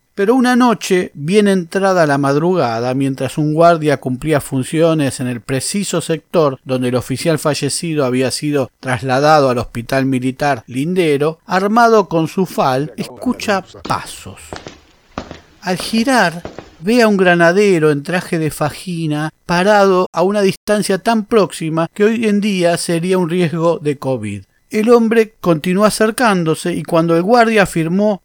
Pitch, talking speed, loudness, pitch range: 165 Hz, 140 wpm, -15 LUFS, 140-200 Hz